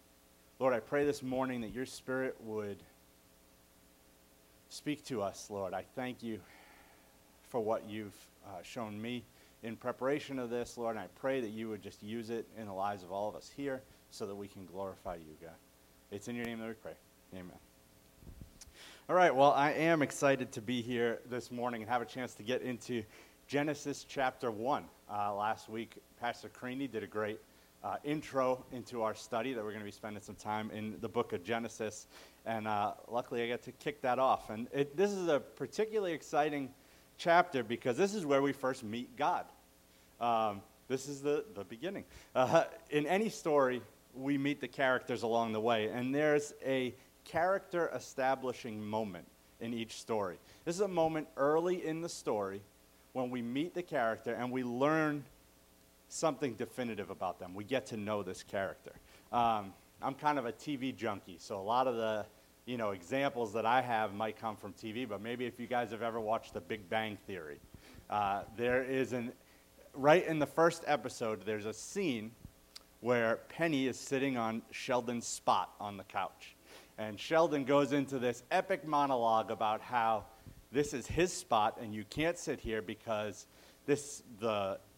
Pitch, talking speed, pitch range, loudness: 115 Hz, 185 wpm, 105-135 Hz, -36 LUFS